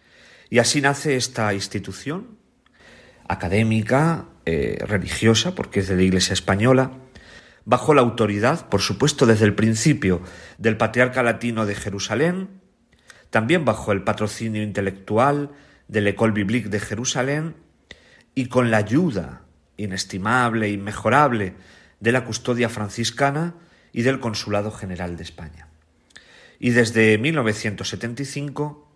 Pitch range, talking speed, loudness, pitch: 100-130 Hz, 120 wpm, -21 LUFS, 110 Hz